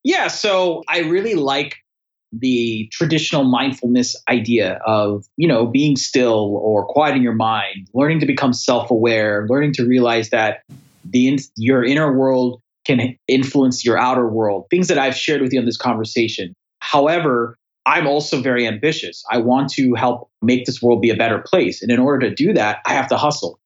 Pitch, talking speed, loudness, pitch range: 125 Hz, 185 wpm, -17 LUFS, 115-140 Hz